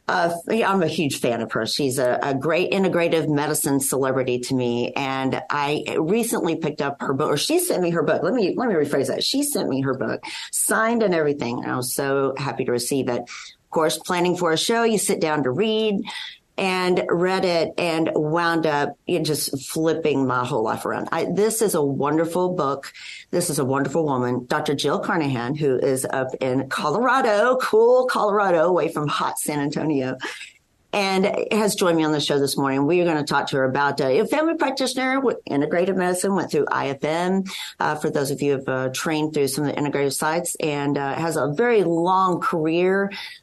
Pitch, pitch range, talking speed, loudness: 155 Hz, 140-180 Hz, 205 wpm, -22 LUFS